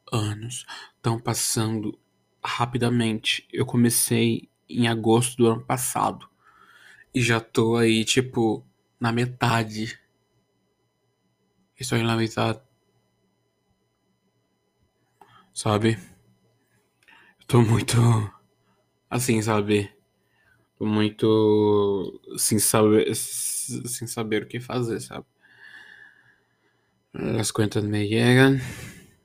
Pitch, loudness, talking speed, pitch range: 115 Hz, -23 LUFS, 85 wpm, 110-120 Hz